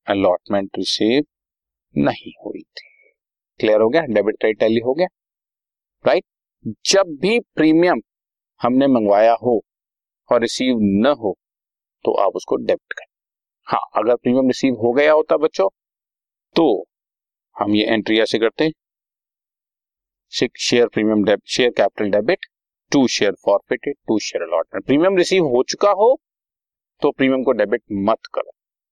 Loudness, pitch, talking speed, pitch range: -18 LUFS, 130 Hz, 135 wpm, 110-165 Hz